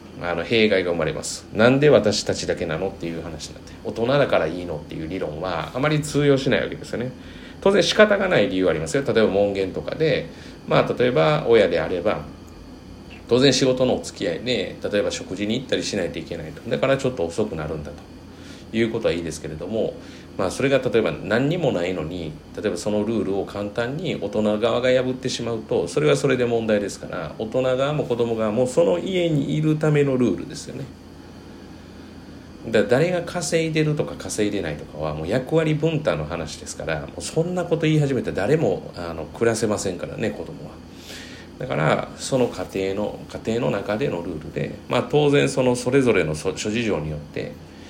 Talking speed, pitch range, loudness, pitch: 395 characters per minute, 85-135 Hz, -22 LUFS, 110 Hz